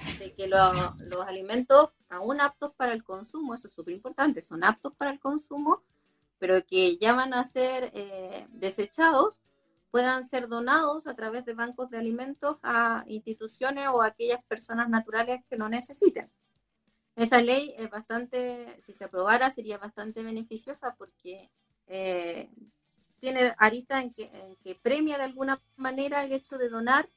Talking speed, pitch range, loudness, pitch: 155 wpm, 210-270 Hz, -28 LUFS, 235 Hz